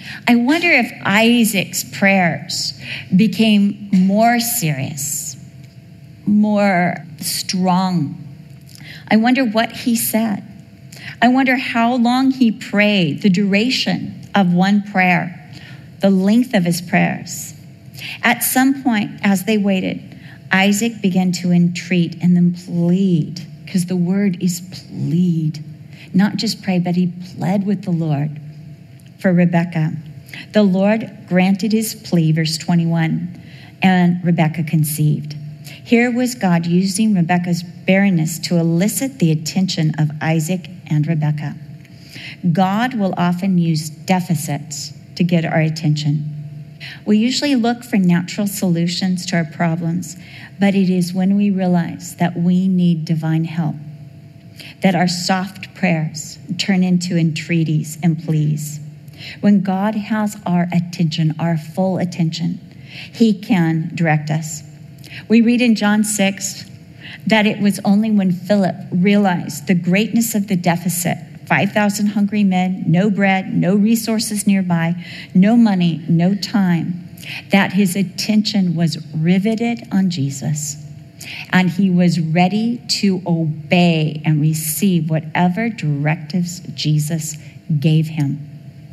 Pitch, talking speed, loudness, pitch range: 175 Hz, 125 wpm, -17 LUFS, 155-195 Hz